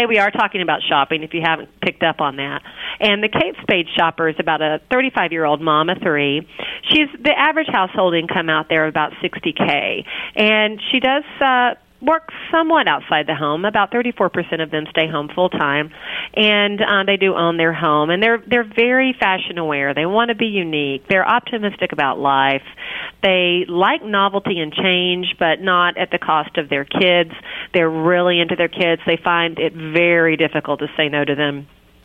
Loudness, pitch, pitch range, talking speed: -17 LUFS, 175 Hz, 155-210 Hz, 195 wpm